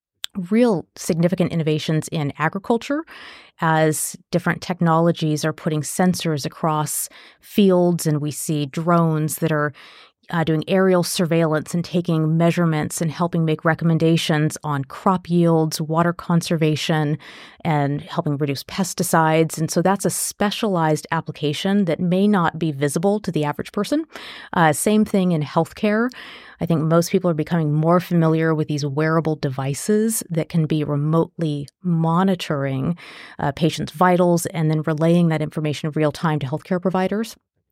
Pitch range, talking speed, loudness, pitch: 155-180 Hz, 145 wpm, -20 LUFS, 165 Hz